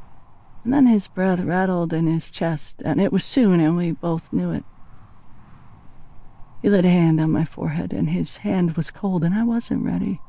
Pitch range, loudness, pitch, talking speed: 165-205 Hz, -21 LUFS, 180 Hz, 195 wpm